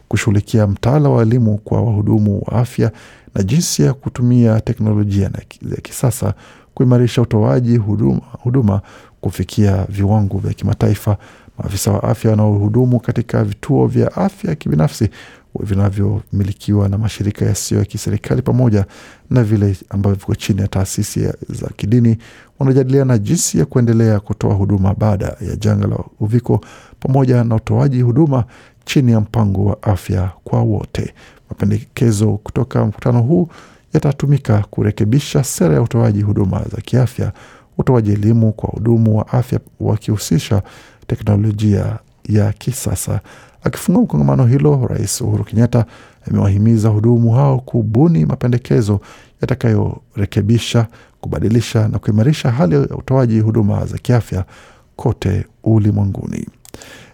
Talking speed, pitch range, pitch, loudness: 125 wpm, 105-125 Hz, 110 Hz, -16 LUFS